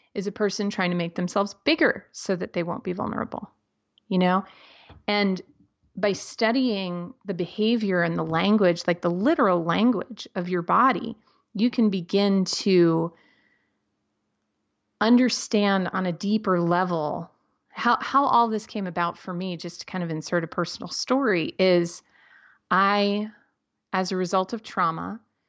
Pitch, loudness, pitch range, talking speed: 190 Hz, -24 LUFS, 175-215 Hz, 150 wpm